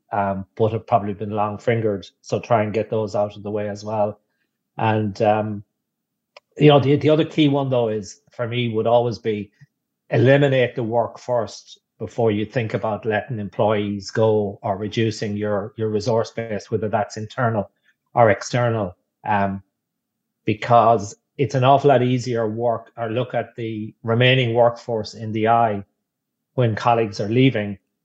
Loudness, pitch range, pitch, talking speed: -21 LUFS, 105-120 Hz, 110 Hz, 165 wpm